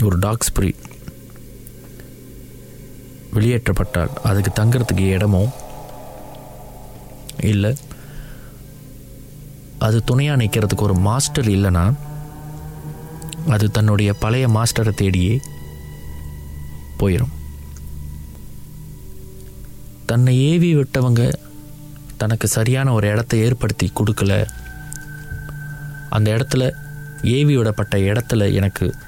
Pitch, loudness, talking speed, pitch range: 115 Hz, -18 LUFS, 70 wpm, 100-140 Hz